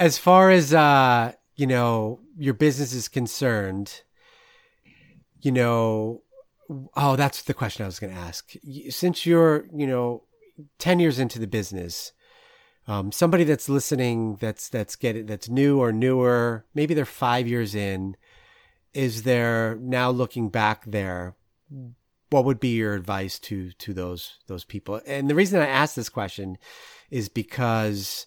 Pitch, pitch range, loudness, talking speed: 125 Hz, 110-145 Hz, -23 LUFS, 155 wpm